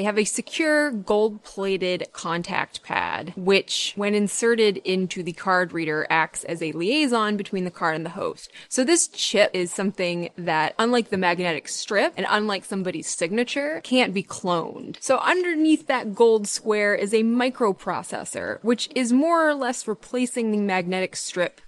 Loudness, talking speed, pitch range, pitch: -23 LUFS, 165 wpm, 180-240 Hz, 205 Hz